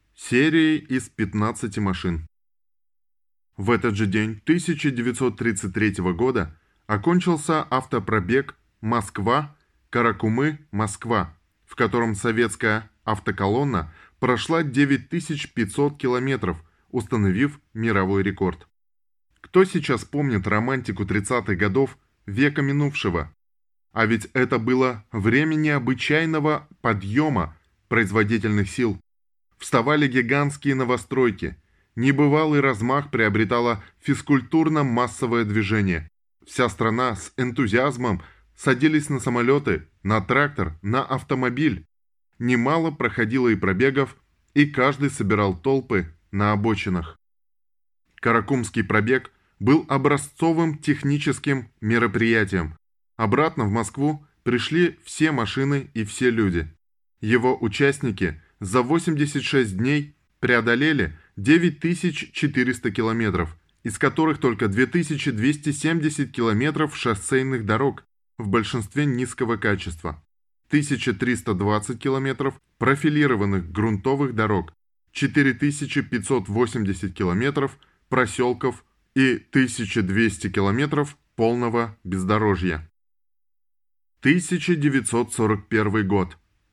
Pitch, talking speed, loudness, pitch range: 120 Hz, 80 wpm, -22 LUFS, 105-140 Hz